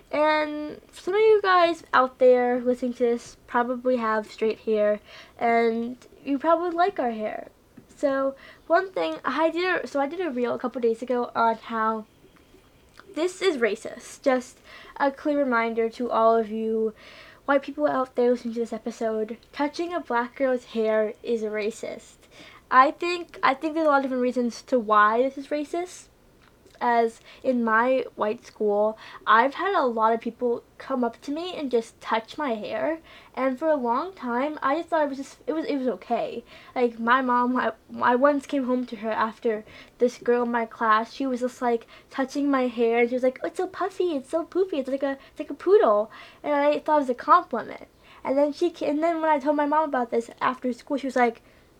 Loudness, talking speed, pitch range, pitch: -25 LUFS, 205 wpm, 230-300 Hz, 255 Hz